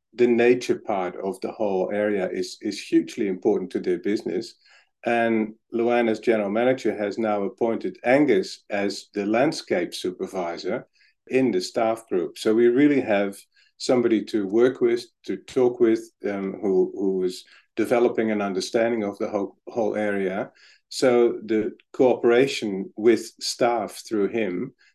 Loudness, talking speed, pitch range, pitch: -24 LUFS, 145 wpm, 105-140 Hz, 115 Hz